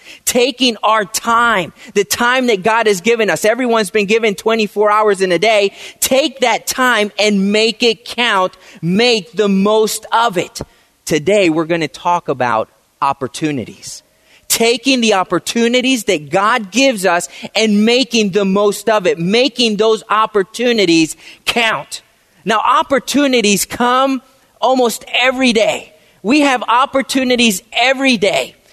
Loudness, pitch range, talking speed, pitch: -13 LUFS, 200-245 Hz, 135 wpm, 220 Hz